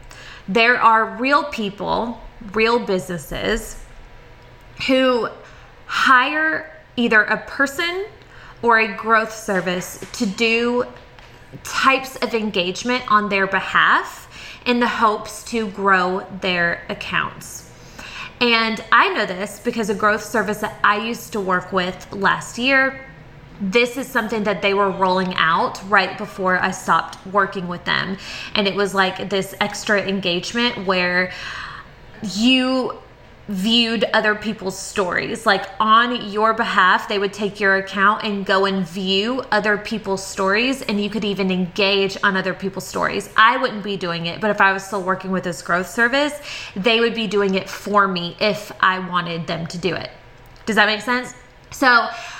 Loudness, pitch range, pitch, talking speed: -19 LUFS, 190-230 Hz, 205 Hz, 150 wpm